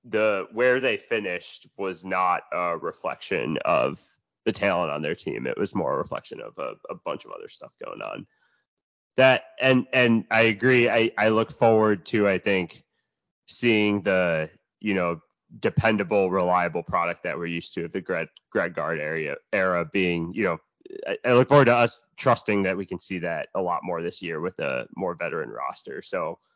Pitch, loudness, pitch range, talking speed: 115 Hz, -24 LUFS, 95-130 Hz, 190 wpm